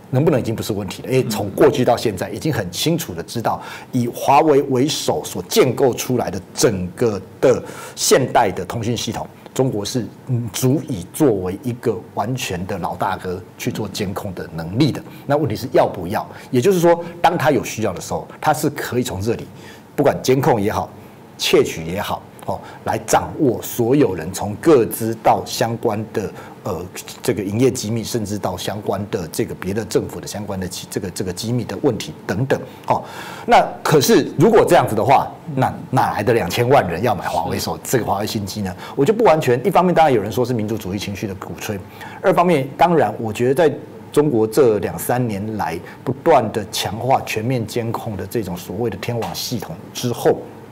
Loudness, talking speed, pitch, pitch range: -19 LUFS, 290 characters per minute, 115 Hz, 100-130 Hz